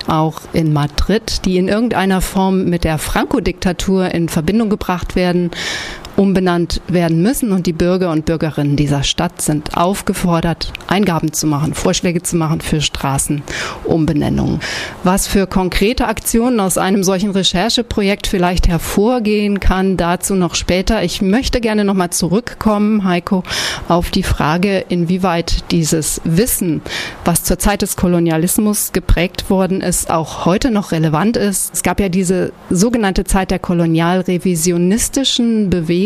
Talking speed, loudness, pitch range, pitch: 135 wpm, -15 LUFS, 170-200 Hz, 185 Hz